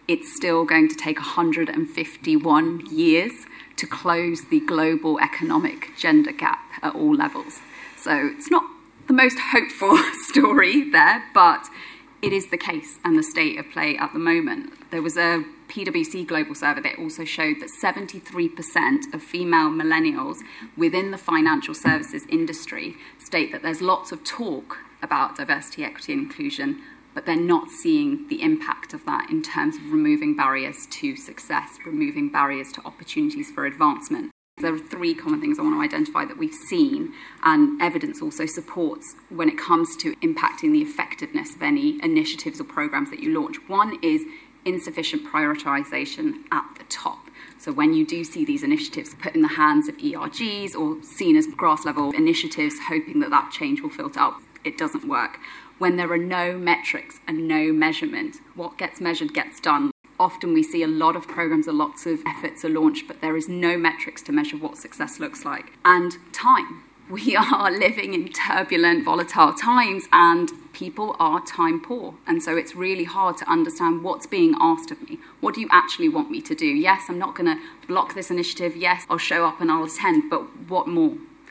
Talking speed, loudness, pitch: 180 wpm, -22 LUFS, 295 Hz